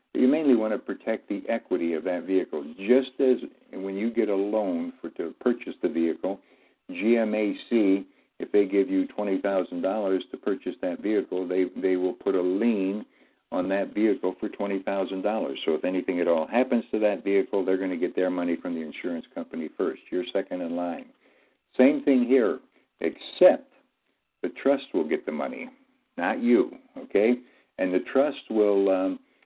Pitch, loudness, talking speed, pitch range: 100 Hz, -26 LUFS, 175 wpm, 95-120 Hz